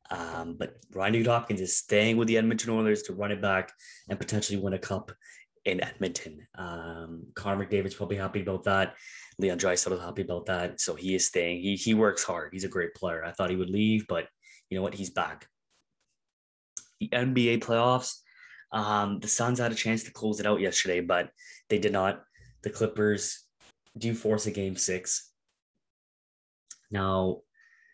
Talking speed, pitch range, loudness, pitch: 180 wpm, 95-110 Hz, -29 LUFS, 105 Hz